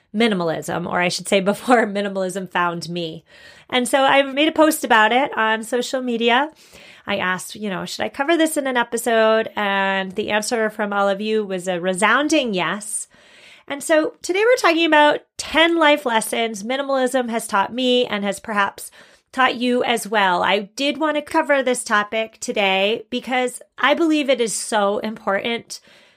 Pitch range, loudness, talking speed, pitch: 200-270 Hz, -19 LUFS, 175 wpm, 230 Hz